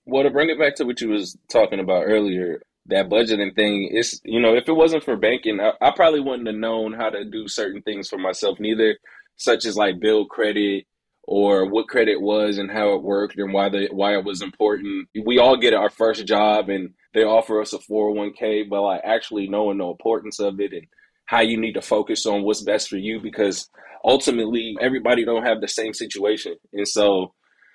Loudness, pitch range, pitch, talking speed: -21 LUFS, 100-120 Hz, 110 Hz, 215 wpm